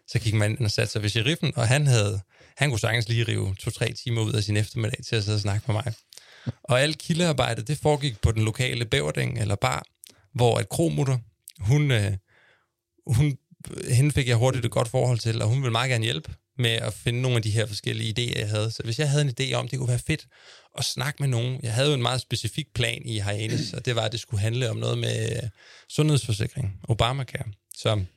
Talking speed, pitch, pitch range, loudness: 230 wpm, 120 Hz, 110-130 Hz, -25 LUFS